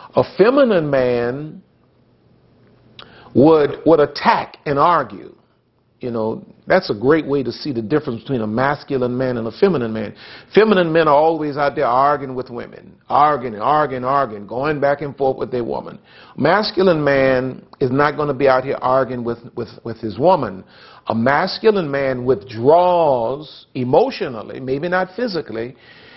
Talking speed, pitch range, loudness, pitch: 155 wpm, 120-150 Hz, -17 LUFS, 135 Hz